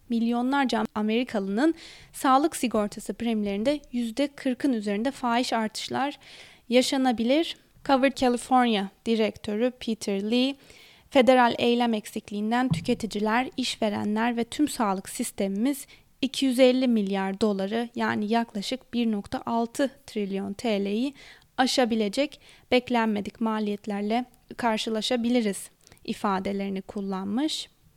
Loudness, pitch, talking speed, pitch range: -26 LUFS, 235 Hz, 80 wpm, 215-255 Hz